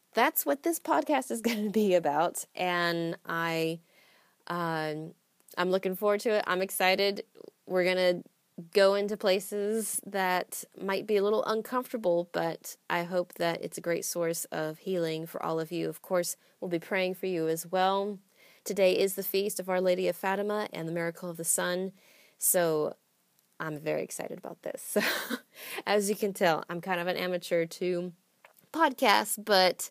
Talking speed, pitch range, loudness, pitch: 175 wpm, 170-205 Hz, -30 LUFS, 185 Hz